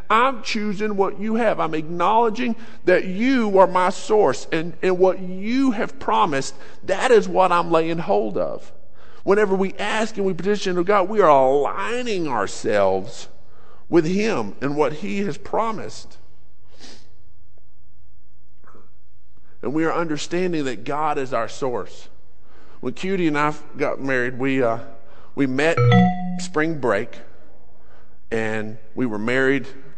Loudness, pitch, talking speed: -21 LUFS, 155 Hz, 140 wpm